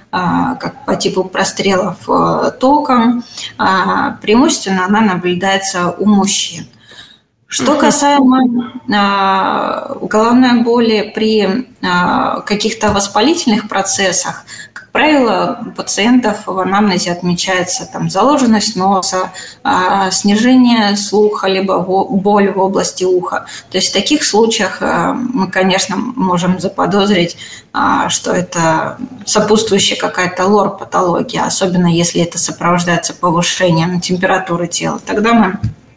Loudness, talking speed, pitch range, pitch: -13 LUFS, 100 wpm, 185-235 Hz, 200 Hz